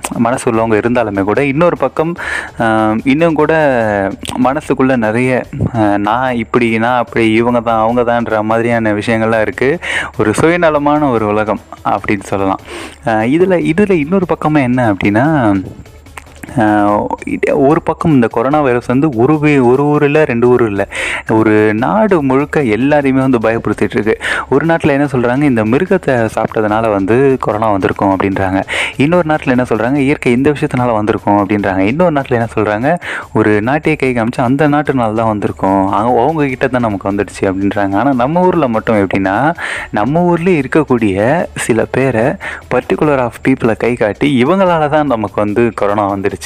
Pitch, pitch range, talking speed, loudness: 120 Hz, 105-145 Hz, 140 wpm, -12 LUFS